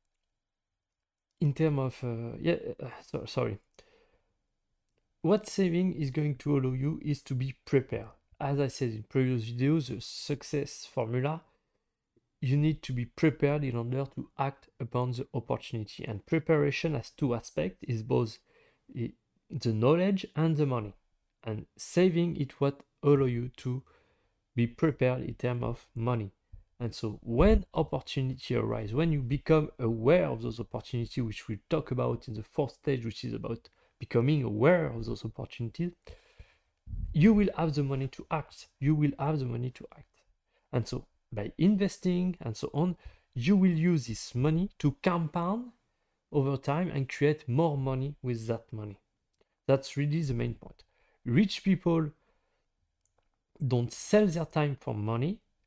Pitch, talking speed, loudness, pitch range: 135 Hz, 150 wpm, -31 LUFS, 120-155 Hz